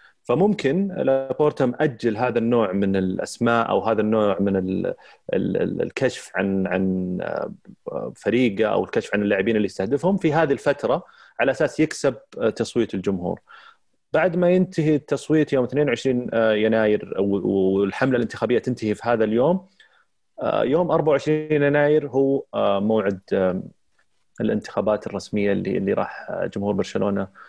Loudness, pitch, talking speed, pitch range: -22 LUFS, 115 Hz, 120 wpm, 100-150 Hz